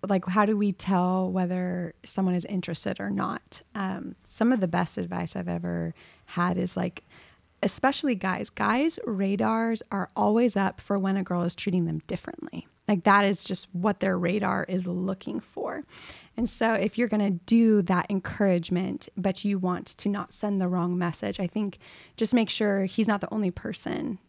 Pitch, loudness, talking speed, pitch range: 195 Hz, -26 LUFS, 185 wpm, 180-210 Hz